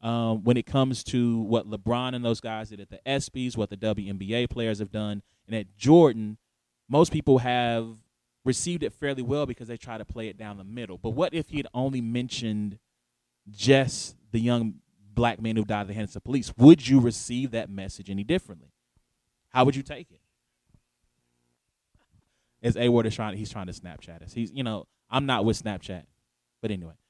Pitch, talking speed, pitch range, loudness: 115 Hz, 200 wpm, 105-125 Hz, -26 LUFS